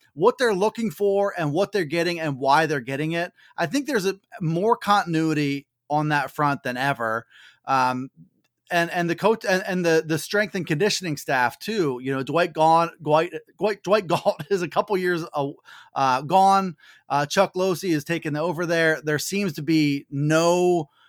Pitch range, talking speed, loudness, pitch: 145-195 Hz, 180 wpm, -23 LUFS, 170 Hz